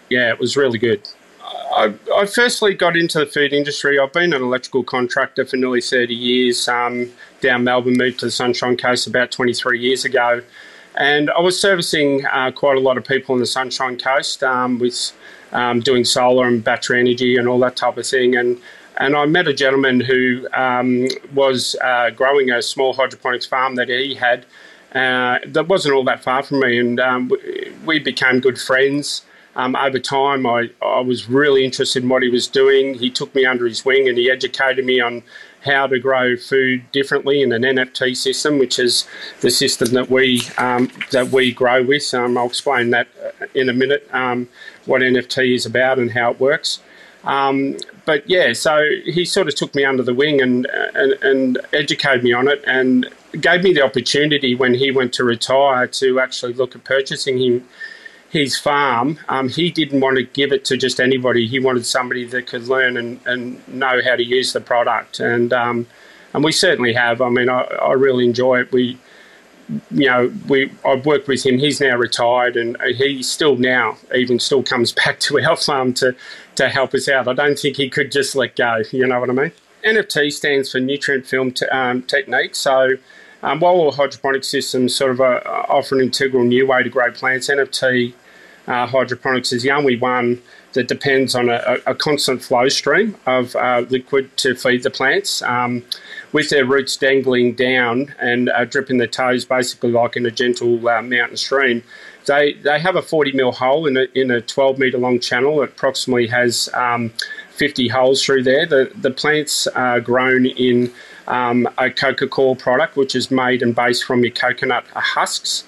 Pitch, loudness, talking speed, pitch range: 130 Hz, -16 LUFS, 195 wpm, 125-140 Hz